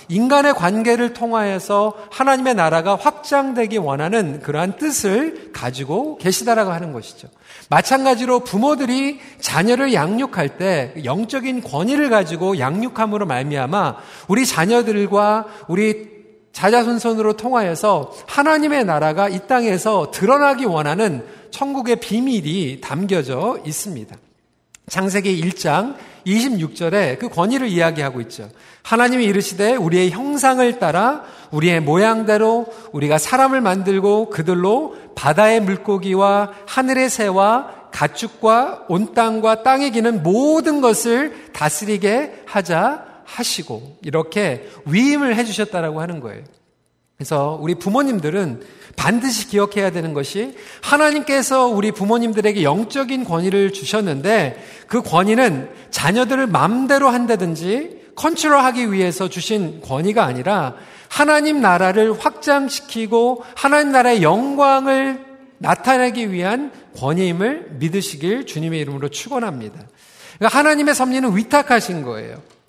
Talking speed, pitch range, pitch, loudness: 300 characters per minute, 175-255 Hz, 215 Hz, -17 LUFS